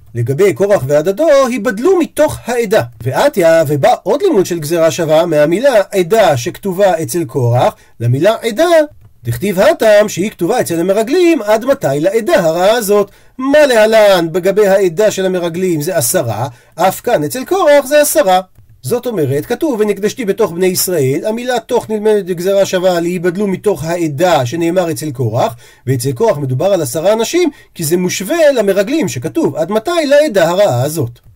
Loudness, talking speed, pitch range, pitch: -12 LUFS, 150 wpm, 160-235 Hz, 195 Hz